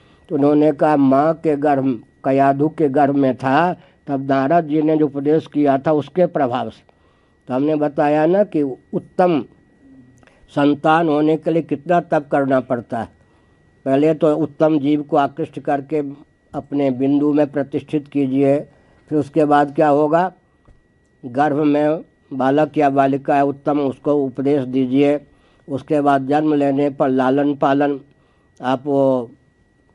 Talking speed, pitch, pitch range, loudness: 145 wpm, 145 Hz, 135-155 Hz, -17 LUFS